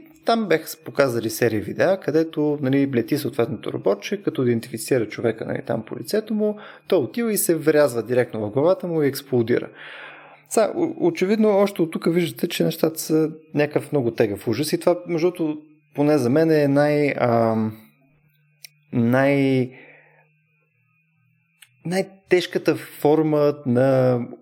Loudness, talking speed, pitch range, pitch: -21 LUFS, 140 wpm, 130-170 Hz, 150 Hz